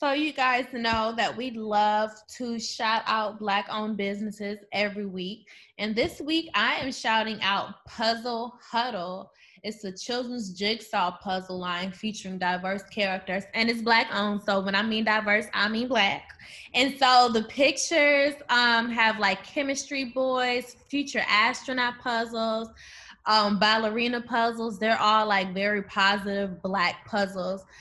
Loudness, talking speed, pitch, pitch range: -26 LUFS, 140 wpm, 220 Hz, 200-240 Hz